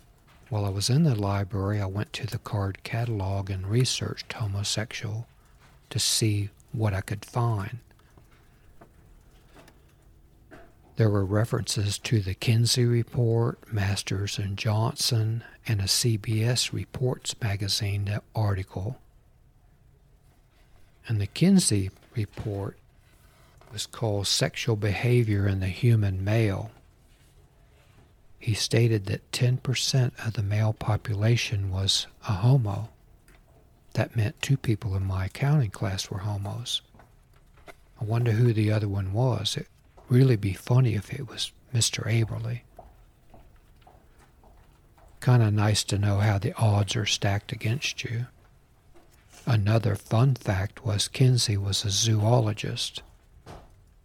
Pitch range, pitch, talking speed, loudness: 100-120 Hz, 110 Hz, 120 wpm, -26 LUFS